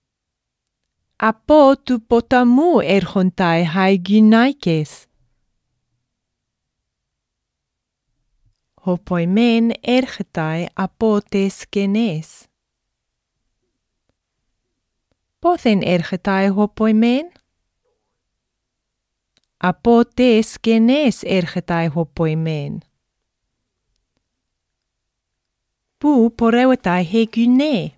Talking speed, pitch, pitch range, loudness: 50 wpm, 195 Hz, 160-235 Hz, -16 LUFS